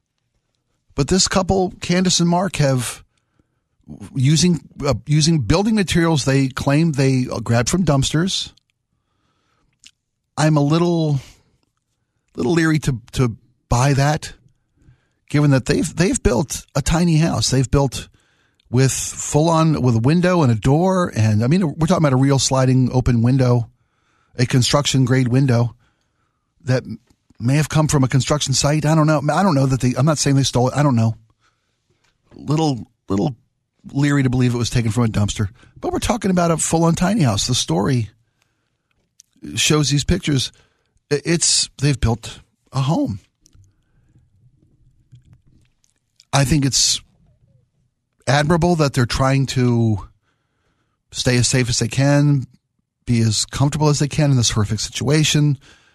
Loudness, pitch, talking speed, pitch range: -18 LUFS, 135 Hz, 150 wpm, 120-150 Hz